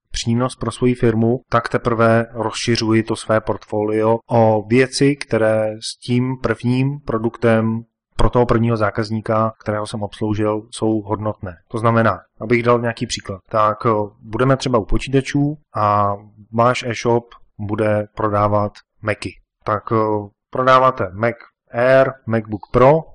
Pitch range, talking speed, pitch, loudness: 110-120 Hz, 125 wpm, 115 Hz, -18 LUFS